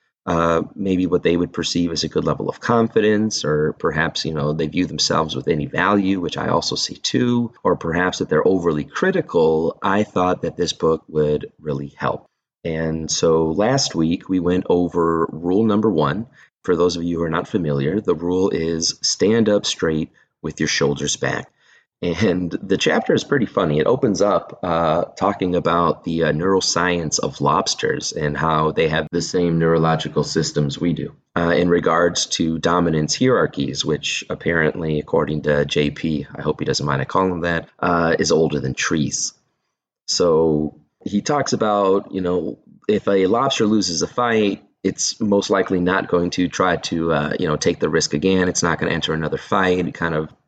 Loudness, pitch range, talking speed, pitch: -19 LUFS, 80-95 Hz, 190 wpm, 85 Hz